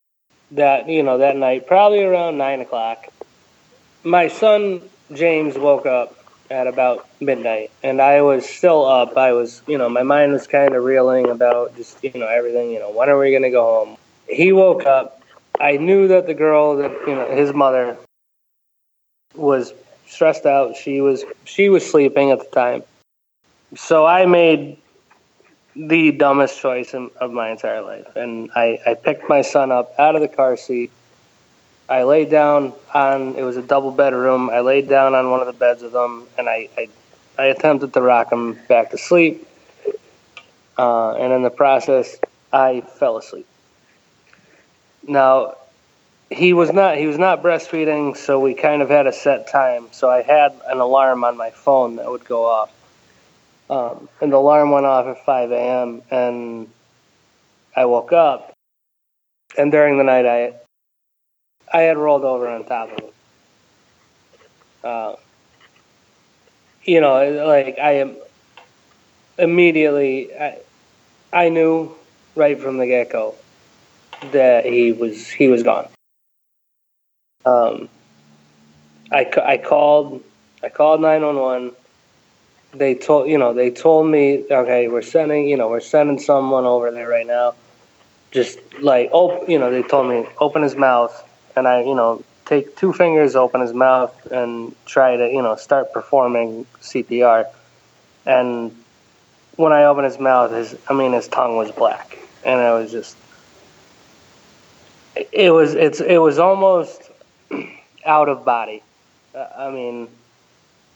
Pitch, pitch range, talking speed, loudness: 135 Hz, 120-150 Hz, 155 wpm, -16 LUFS